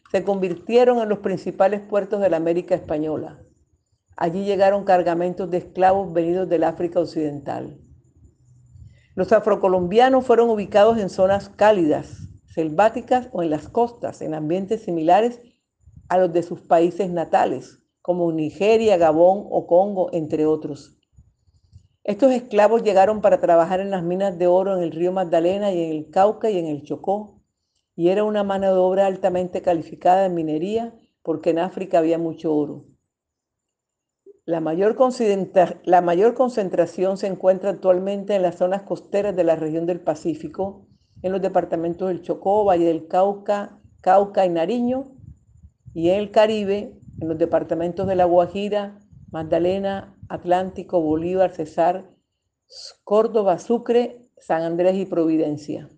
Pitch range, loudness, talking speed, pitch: 170-200 Hz, -20 LUFS, 145 wpm, 185 Hz